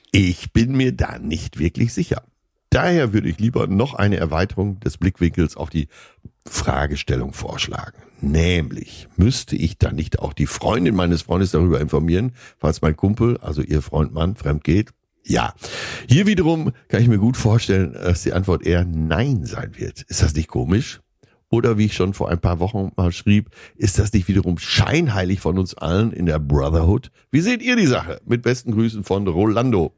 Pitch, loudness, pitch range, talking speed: 95 Hz, -20 LUFS, 85-115 Hz, 180 wpm